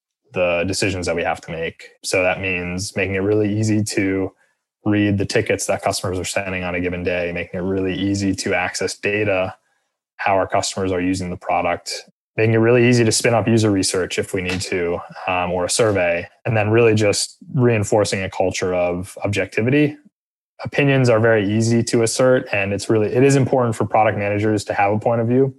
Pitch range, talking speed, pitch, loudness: 95-115 Hz, 205 wpm, 100 Hz, -19 LUFS